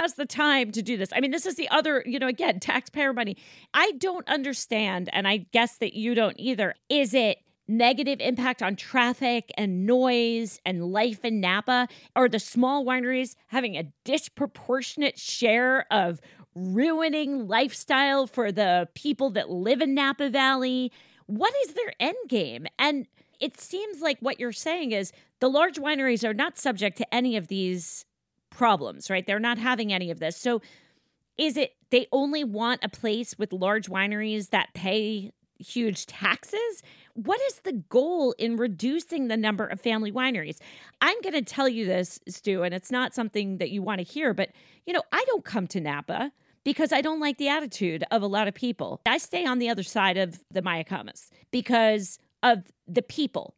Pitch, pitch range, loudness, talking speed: 245 Hz, 205-275 Hz, -26 LUFS, 185 wpm